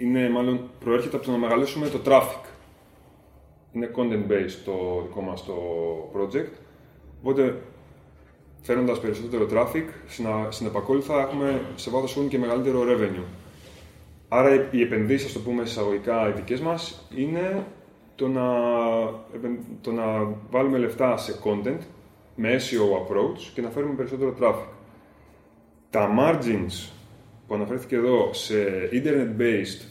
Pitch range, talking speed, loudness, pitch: 105-130 Hz, 130 wpm, -25 LUFS, 120 Hz